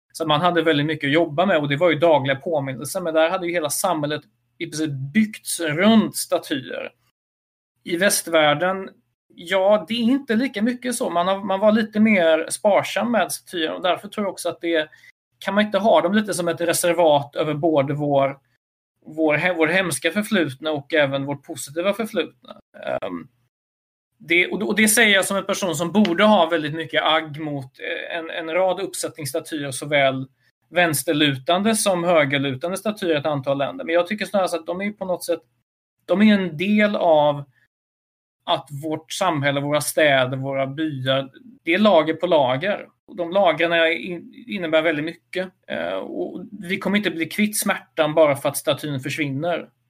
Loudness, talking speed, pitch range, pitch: -20 LUFS, 175 wpm, 145-190 Hz, 165 Hz